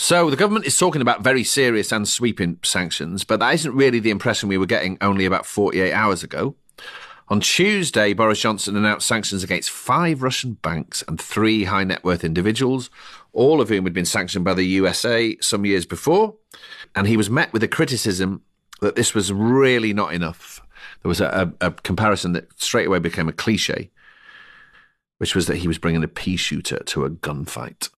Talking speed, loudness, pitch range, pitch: 195 wpm, -20 LUFS, 95-130 Hz, 105 Hz